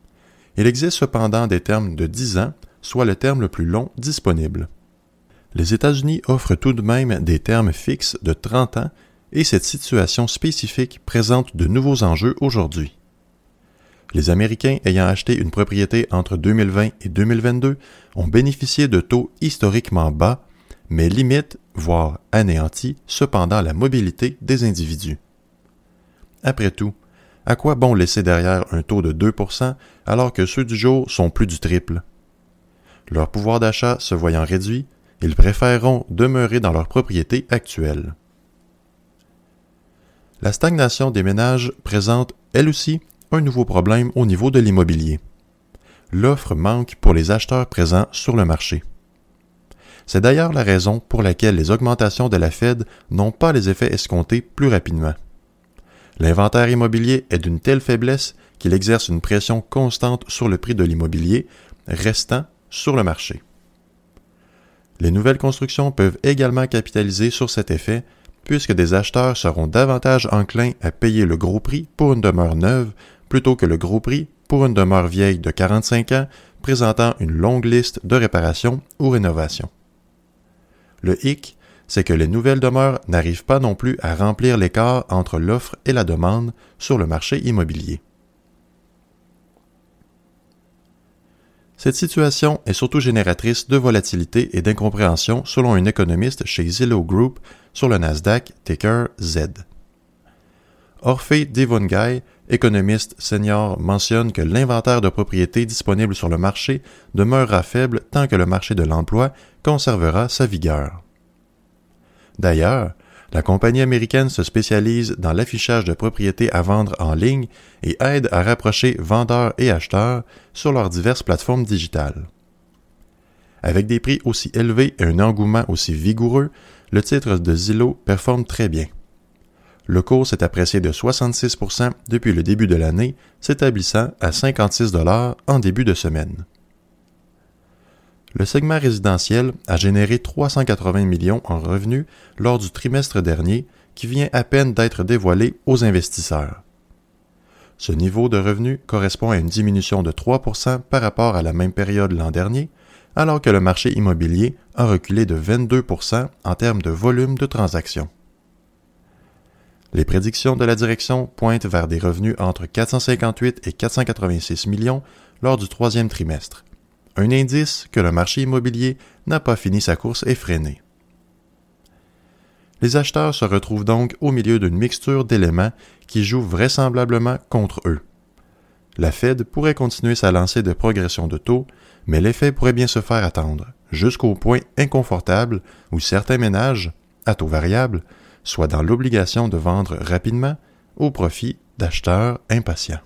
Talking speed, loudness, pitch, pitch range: 145 wpm, -18 LUFS, 110 Hz, 90-125 Hz